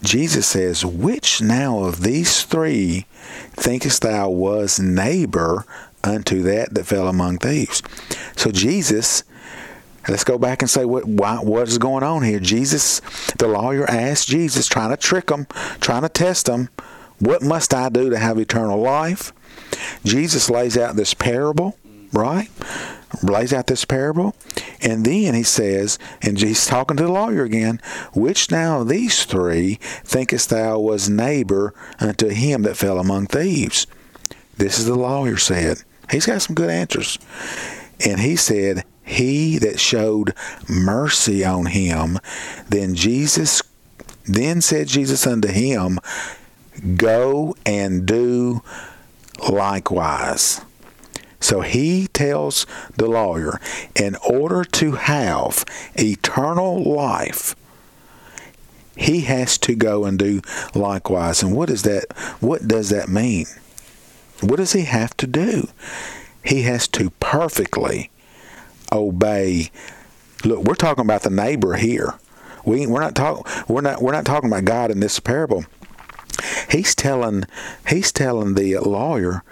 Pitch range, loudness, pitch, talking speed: 100-135 Hz, -18 LUFS, 115 Hz, 135 wpm